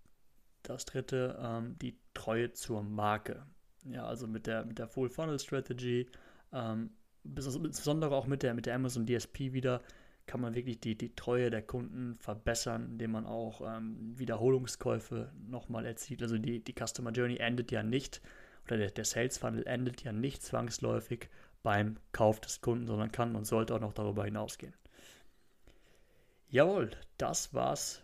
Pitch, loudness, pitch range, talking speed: 120 Hz, -36 LUFS, 110-125 Hz, 150 wpm